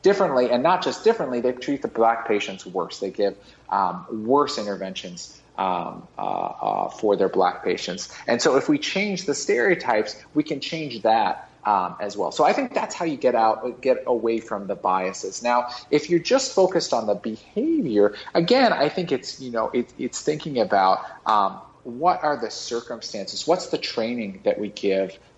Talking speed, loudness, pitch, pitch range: 185 wpm, -23 LUFS, 125 Hz, 110-165 Hz